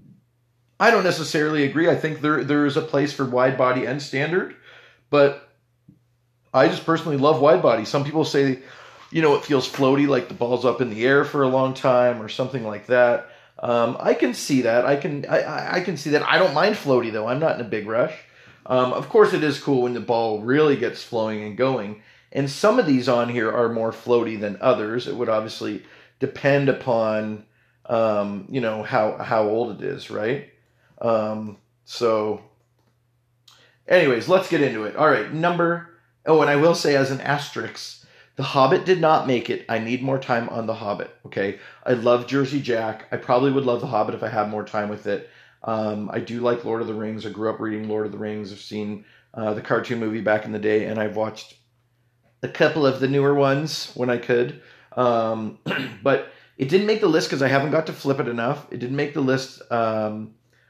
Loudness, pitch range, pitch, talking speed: -22 LUFS, 110-140 Hz, 125 Hz, 215 wpm